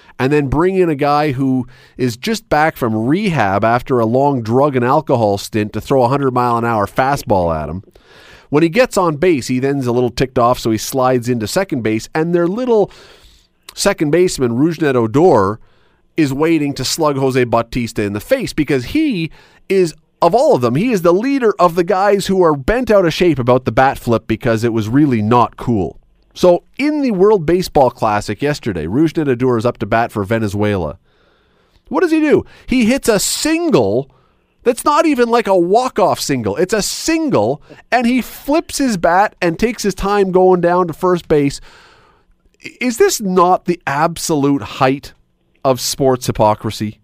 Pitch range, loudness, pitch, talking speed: 125-190 Hz, -15 LUFS, 150 Hz, 190 wpm